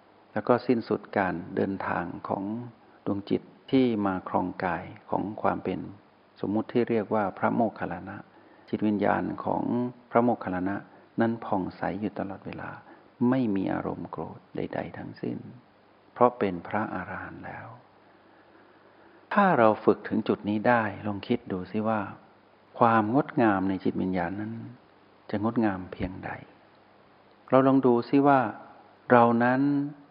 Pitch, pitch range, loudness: 110 Hz, 100-120 Hz, -27 LUFS